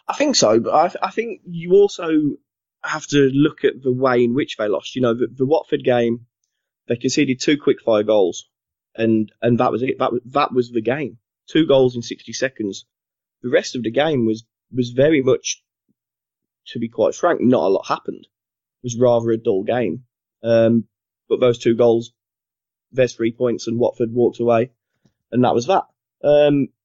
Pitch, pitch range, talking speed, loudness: 120 Hz, 115-140 Hz, 195 wpm, -19 LUFS